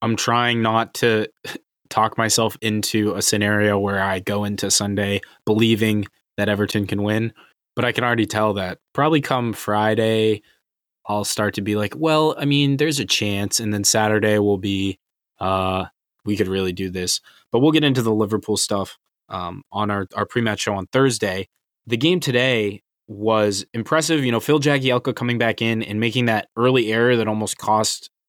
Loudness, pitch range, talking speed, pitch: -20 LUFS, 105-120 Hz, 180 wpm, 110 Hz